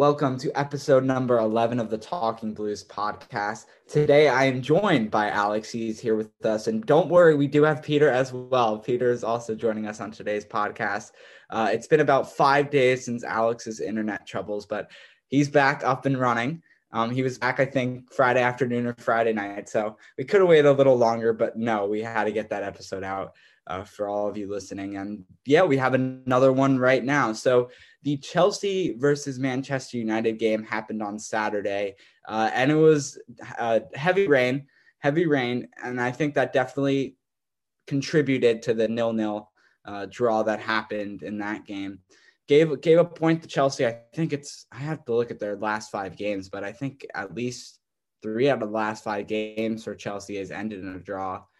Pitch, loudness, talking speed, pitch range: 115 Hz, -24 LUFS, 195 wpm, 105-135 Hz